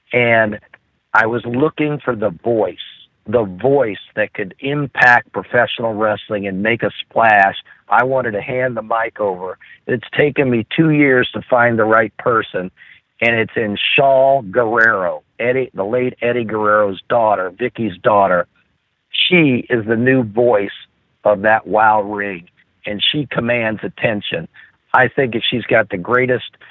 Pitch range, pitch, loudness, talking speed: 105-125 Hz, 115 Hz, -16 LUFS, 155 wpm